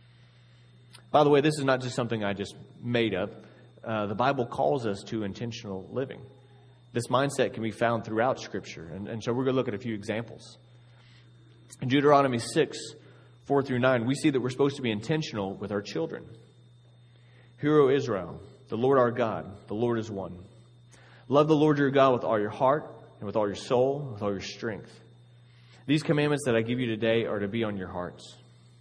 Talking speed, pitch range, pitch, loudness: 200 wpm, 110-130 Hz, 120 Hz, -28 LUFS